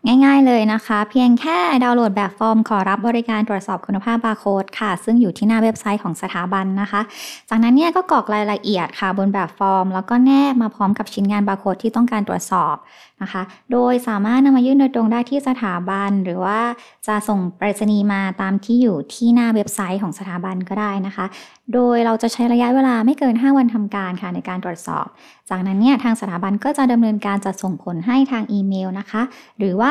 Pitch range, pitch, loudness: 195-240 Hz, 210 Hz, -18 LUFS